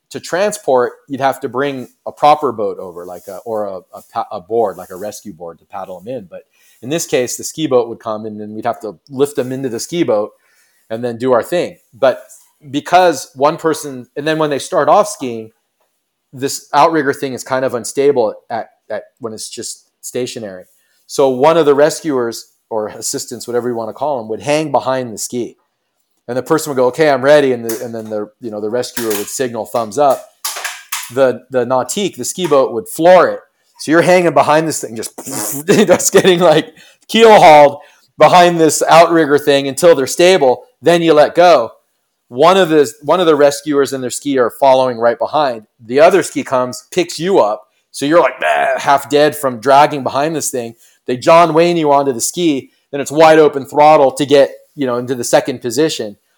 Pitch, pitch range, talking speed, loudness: 140 Hz, 125-160 Hz, 210 wpm, -13 LUFS